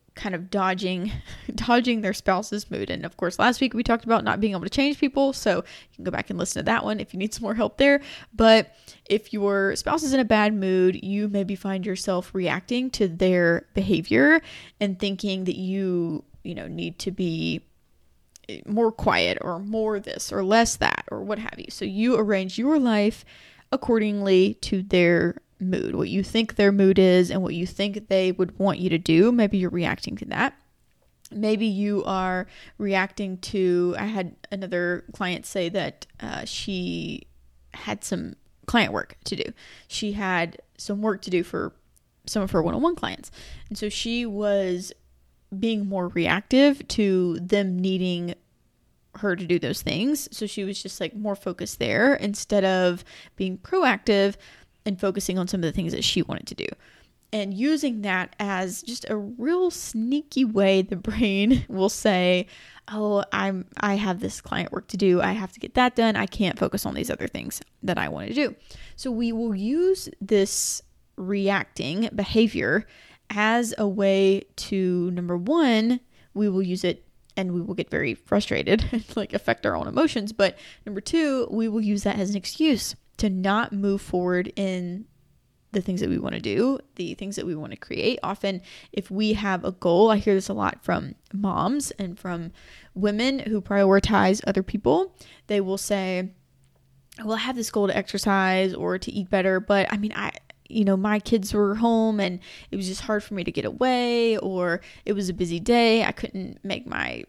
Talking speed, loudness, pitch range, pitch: 190 wpm, -24 LUFS, 185-220 Hz, 200 Hz